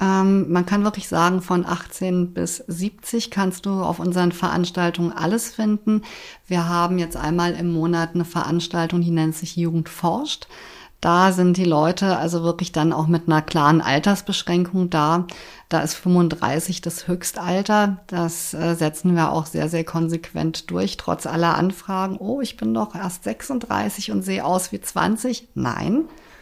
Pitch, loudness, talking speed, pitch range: 175 Hz, -21 LUFS, 155 wpm, 165-190 Hz